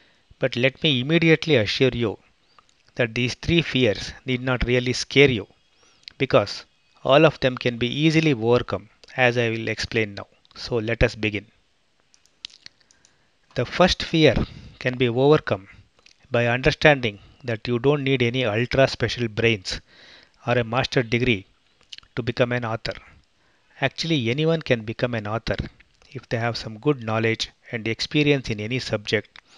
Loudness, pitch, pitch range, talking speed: -22 LUFS, 120 Hz, 115-135 Hz, 150 wpm